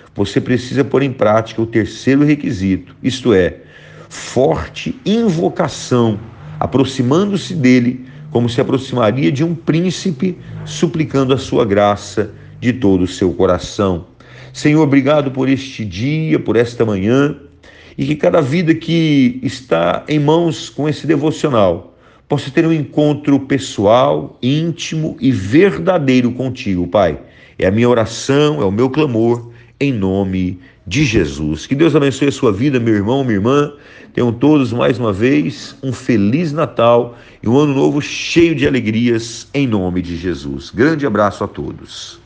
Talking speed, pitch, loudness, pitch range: 145 wpm, 130 Hz, -15 LUFS, 115-150 Hz